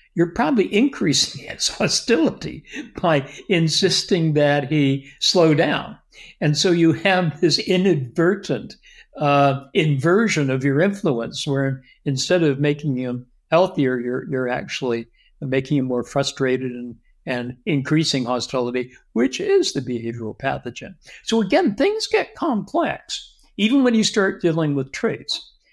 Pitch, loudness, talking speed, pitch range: 145 Hz, -20 LUFS, 130 wpm, 130-185 Hz